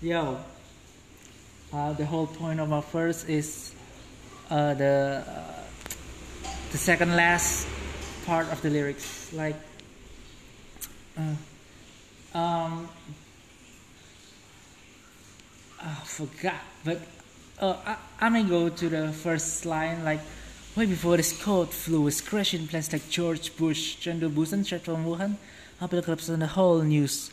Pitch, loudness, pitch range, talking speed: 160 Hz, -28 LUFS, 145-170 Hz, 125 wpm